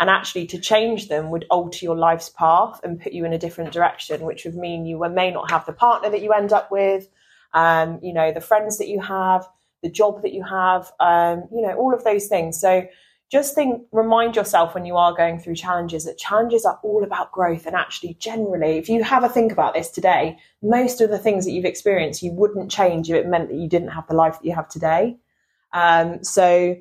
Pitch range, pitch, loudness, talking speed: 170-210 Hz, 180 Hz, -20 LUFS, 235 wpm